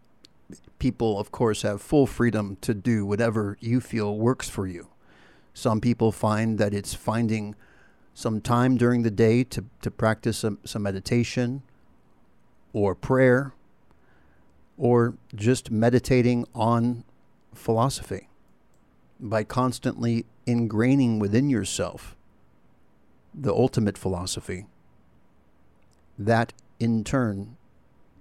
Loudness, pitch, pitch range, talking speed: -25 LUFS, 115 Hz, 100-120 Hz, 105 wpm